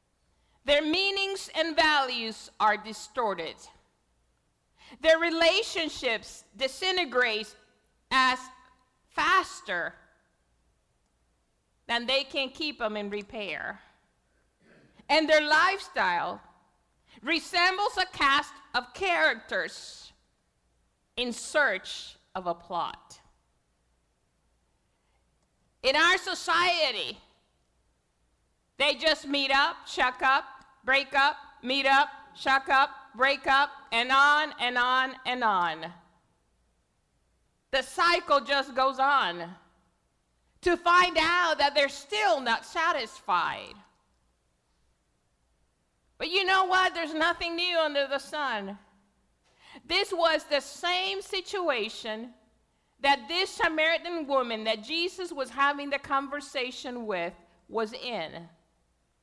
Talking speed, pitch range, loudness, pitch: 95 wpm, 215-320 Hz, -27 LUFS, 275 Hz